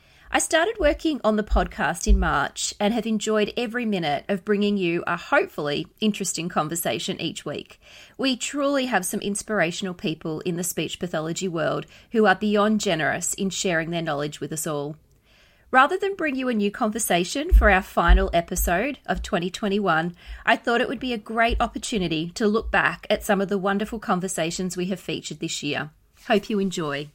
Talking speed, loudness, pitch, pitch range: 180 wpm, -24 LUFS, 200 Hz, 170-225 Hz